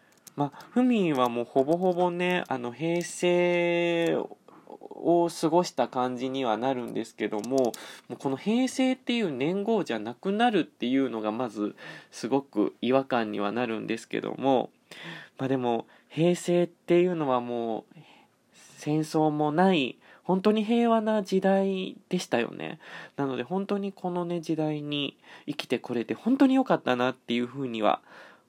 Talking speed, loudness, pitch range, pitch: 295 characters per minute, -27 LUFS, 125-180 Hz, 155 Hz